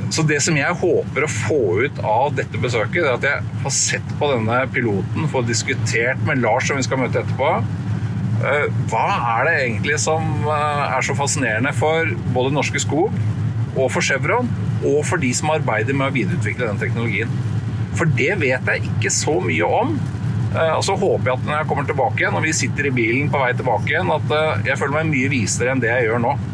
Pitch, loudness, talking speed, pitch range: 130 Hz, -19 LUFS, 200 wpm, 115-145 Hz